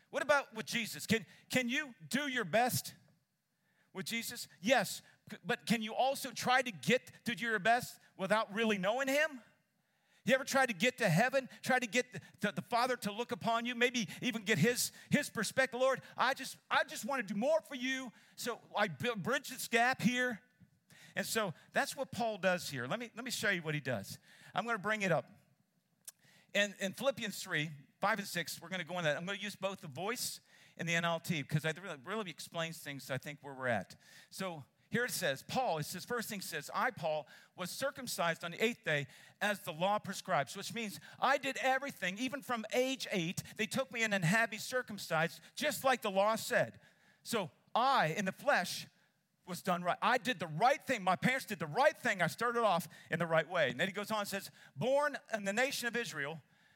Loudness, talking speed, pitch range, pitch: -35 LUFS, 220 wpm, 170-245 Hz, 205 Hz